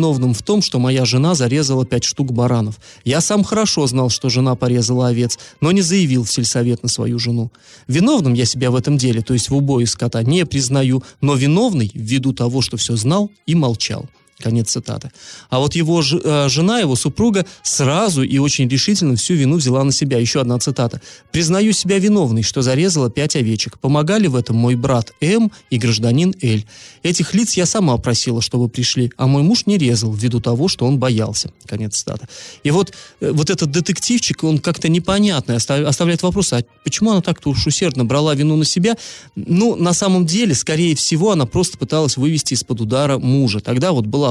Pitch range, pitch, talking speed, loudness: 120-170 Hz, 135 Hz, 190 wpm, -16 LUFS